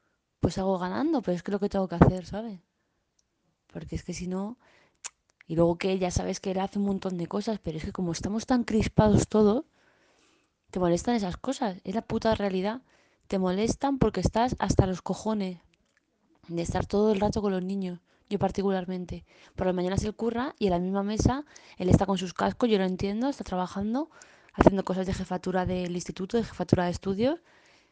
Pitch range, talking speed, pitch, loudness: 185-220 Hz, 200 wpm, 195 Hz, -28 LUFS